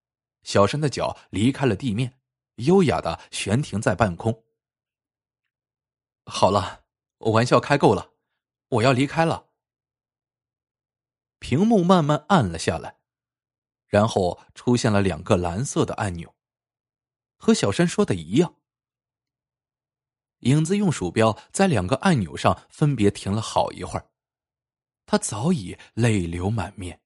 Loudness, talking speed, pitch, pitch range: -22 LUFS, 185 characters per minute, 125 Hz, 105-150 Hz